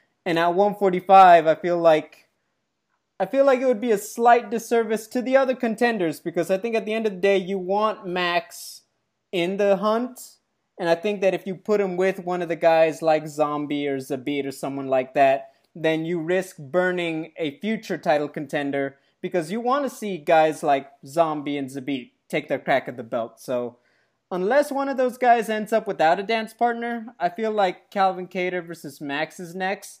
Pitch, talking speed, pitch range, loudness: 180 Hz, 200 wpm, 160-215 Hz, -23 LUFS